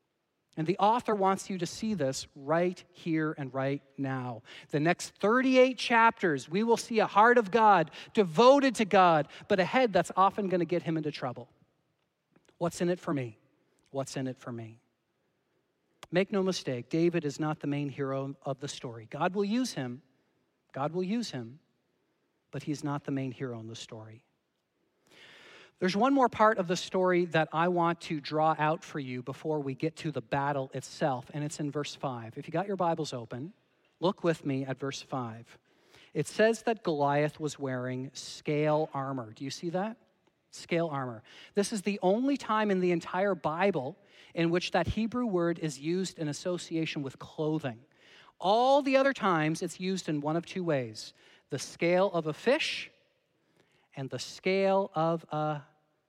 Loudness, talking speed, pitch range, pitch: -30 LUFS, 185 wpm, 140-190 Hz, 160 Hz